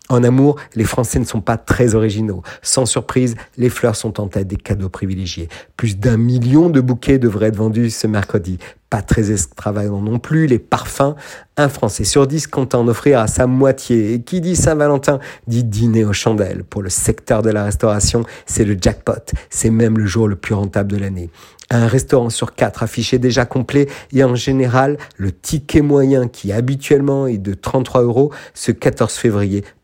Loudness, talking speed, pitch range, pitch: -16 LUFS, 190 wpm, 105-130 Hz, 120 Hz